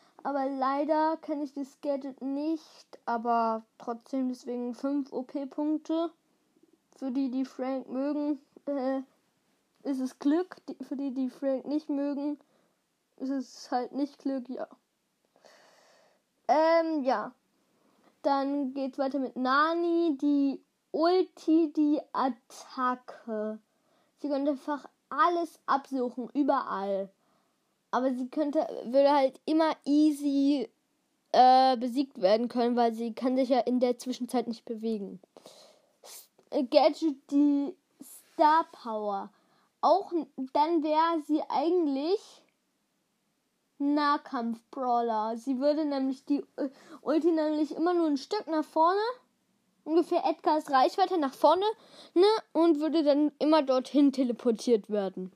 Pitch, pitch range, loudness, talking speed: 280 Hz, 255-310 Hz, -29 LUFS, 115 wpm